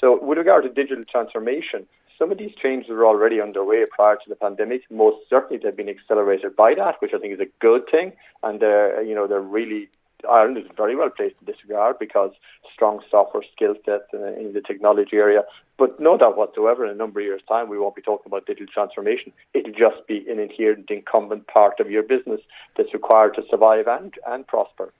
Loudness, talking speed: -20 LUFS, 210 wpm